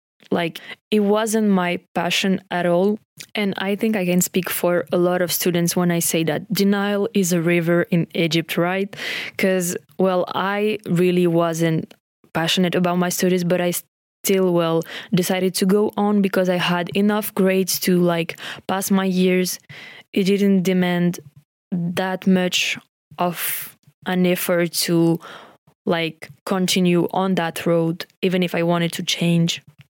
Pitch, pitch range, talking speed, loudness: 180 Hz, 170-190 Hz, 150 wpm, -20 LUFS